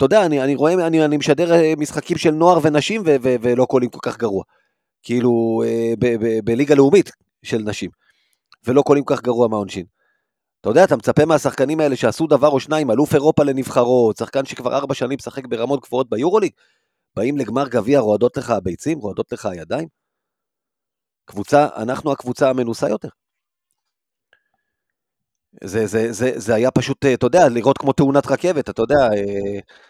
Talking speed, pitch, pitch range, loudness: 160 wpm, 135 Hz, 115-150 Hz, -17 LUFS